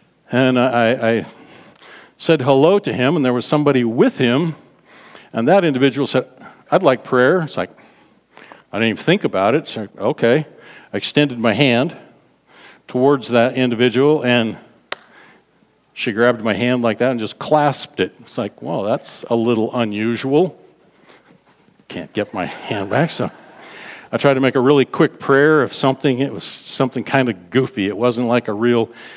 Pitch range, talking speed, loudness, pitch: 120-140 Hz, 175 wpm, -17 LUFS, 125 Hz